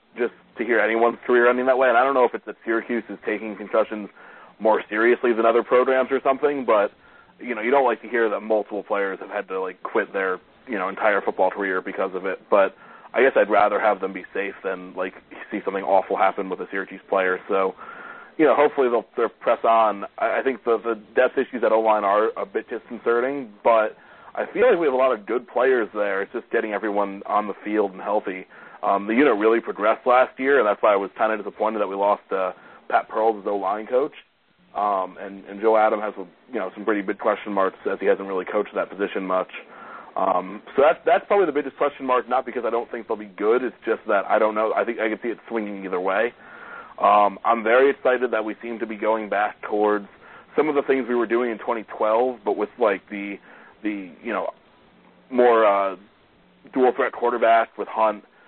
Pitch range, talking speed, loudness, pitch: 100-120 Hz, 230 wpm, -22 LUFS, 110 Hz